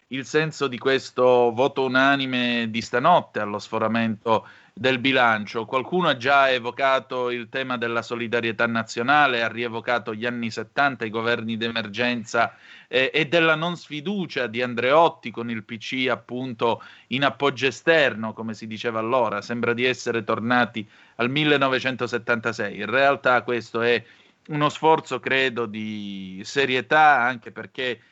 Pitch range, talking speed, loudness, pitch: 115-135 Hz, 135 wpm, -22 LUFS, 120 Hz